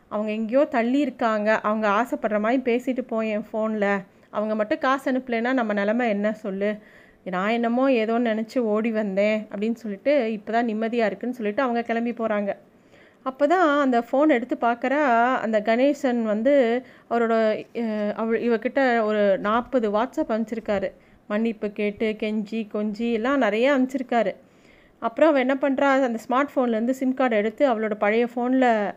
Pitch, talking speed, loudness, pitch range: 230 Hz, 145 wpm, -23 LUFS, 215-255 Hz